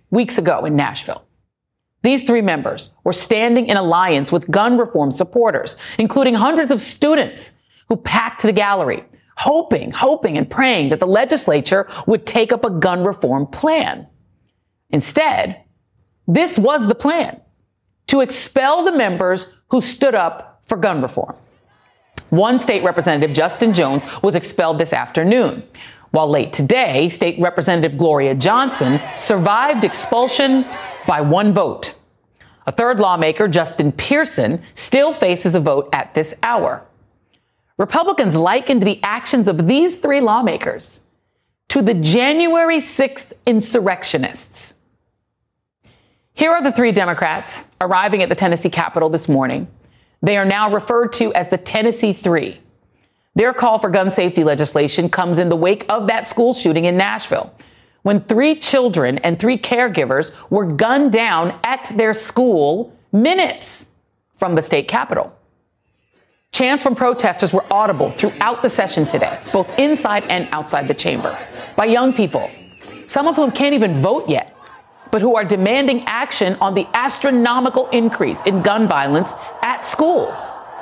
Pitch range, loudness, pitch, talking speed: 180-255 Hz, -16 LUFS, 220 Hz, 140 wpm